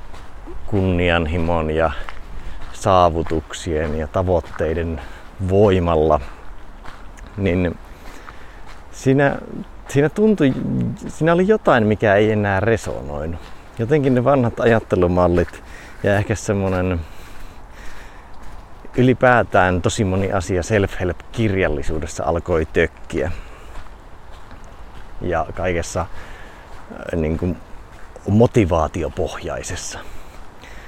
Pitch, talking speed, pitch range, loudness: 90 Hz, 75 wpm, 80-105 Hz, -19 LUFS